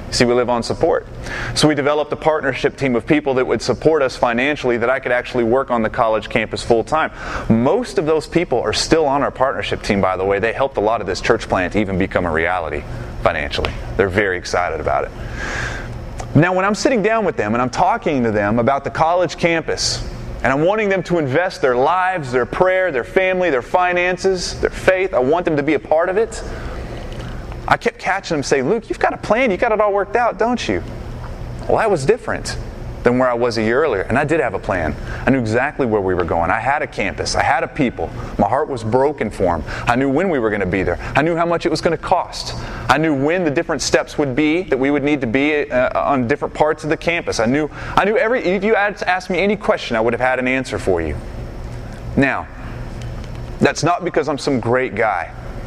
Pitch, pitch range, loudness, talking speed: 145 Hz, 120-175 Hz, -18 LUFS, 240 wpm